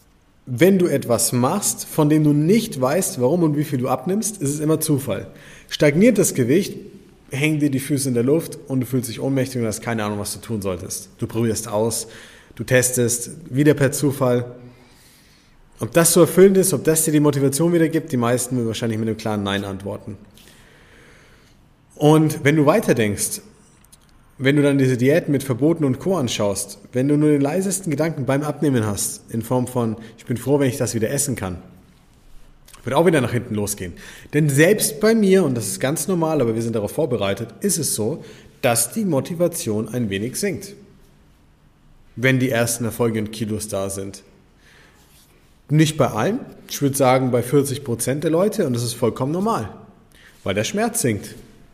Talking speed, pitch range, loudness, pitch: 190 wpm, 115-150 Hz, -19 LUFS, 130 Hz